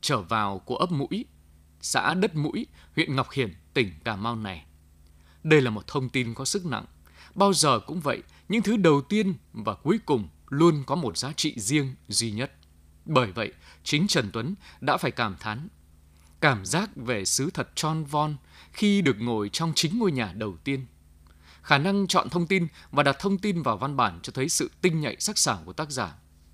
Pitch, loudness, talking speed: 135 Hz, -26 LUFS, 200 wpm